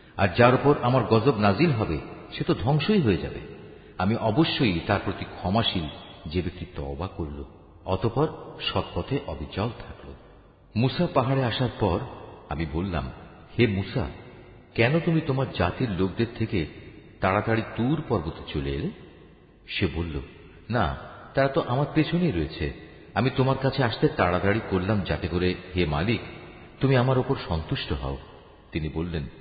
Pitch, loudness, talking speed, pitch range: 100 Hz, -26 LUFS, 140 wpm, 85-125 Hz